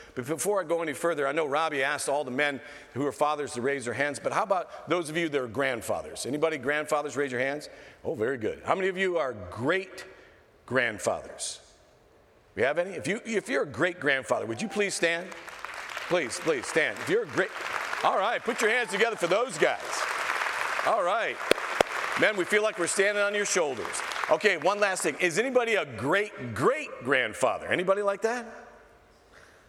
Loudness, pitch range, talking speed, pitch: -28 LUFS, 145-200 Hz, 195 wpm, 170 Hz